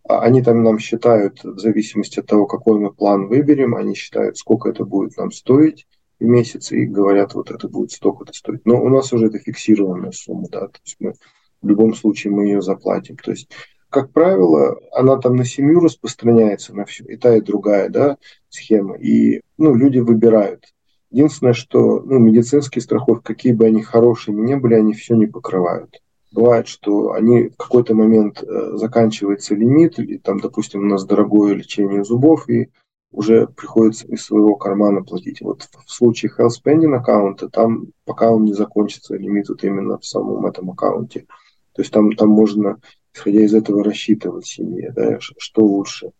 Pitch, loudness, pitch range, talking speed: 110 Hz, -16 LUFS, 105-120 Hz, 175 wpm